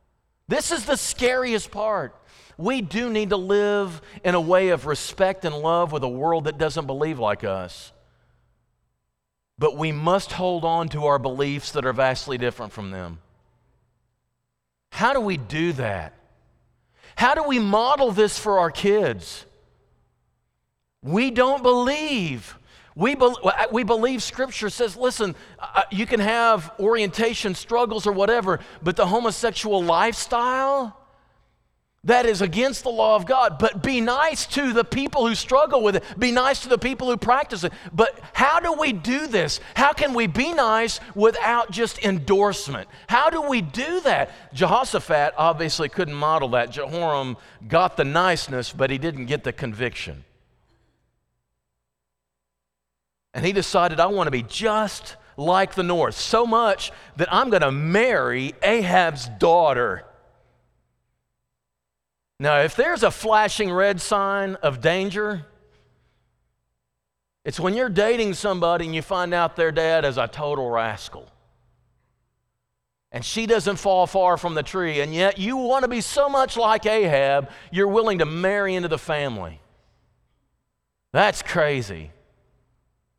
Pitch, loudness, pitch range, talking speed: 185 Hz, -22 LUFS, 140-225 Hz, 145 wpm